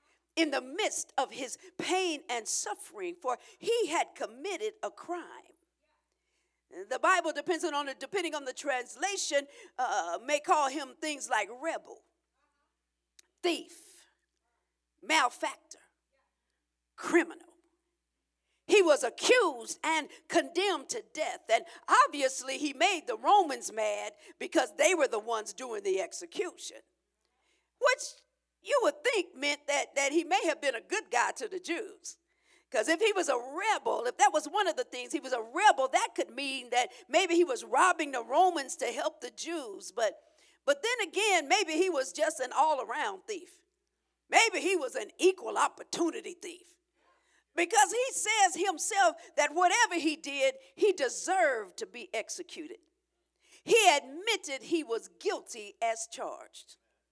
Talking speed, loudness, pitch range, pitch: 150 wpm, -30 LUFS, 295-390 Hz, 345 Hz